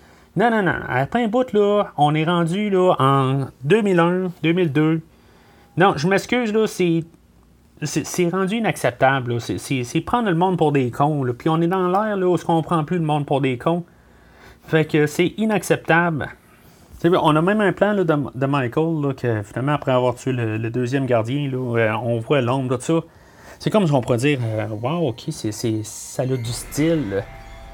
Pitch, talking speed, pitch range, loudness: 150 Hz, 210 wpm, 125-175 Hz, -20 LUFS